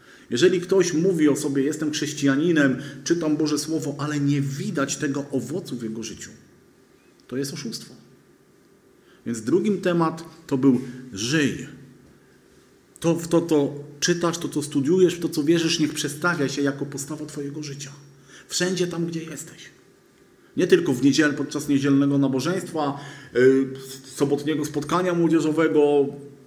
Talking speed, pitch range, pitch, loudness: 135 wpm, 140-165 Hz, 150 Hz, -23 LUFS